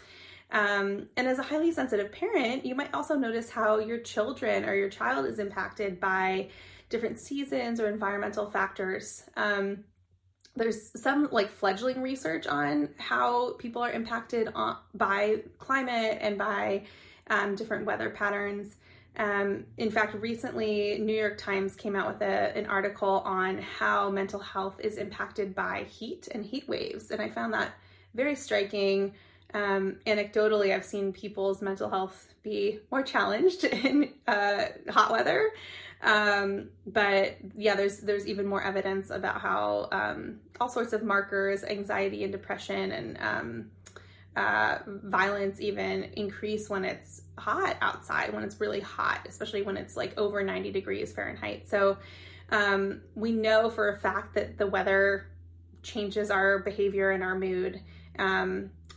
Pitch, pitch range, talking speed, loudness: 205 Hz, 195-220 Hz, 150 wpm, -30 LUFS